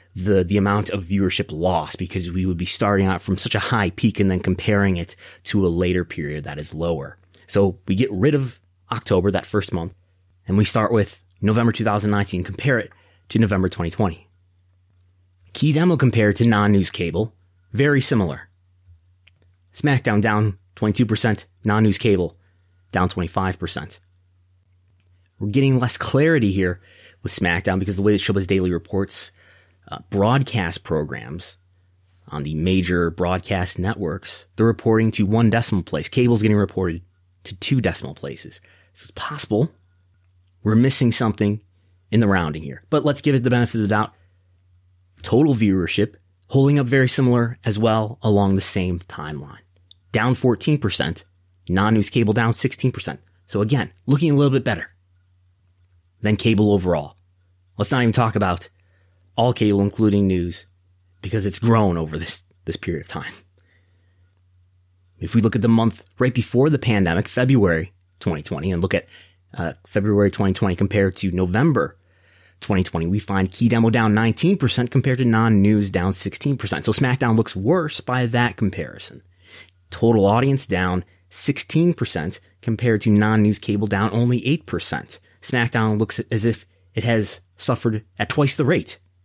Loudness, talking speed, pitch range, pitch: -20 LUFS, 155 wpm, 90-115 Hz, 100 Hz